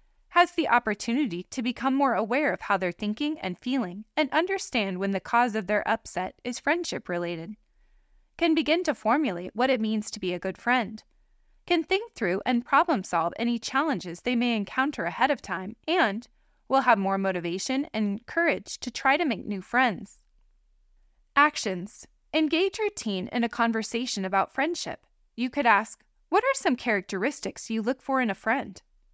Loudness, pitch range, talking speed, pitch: -27 LUFS, 205-285 Hz, 175 wpm, 240 Hz